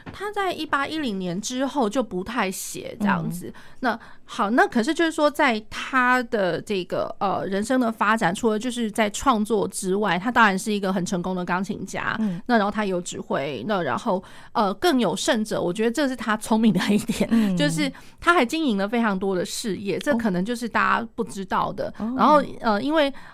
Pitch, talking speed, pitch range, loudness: 220 Hz, 290 characters per minute, 195-255 Hz, -23 LUFS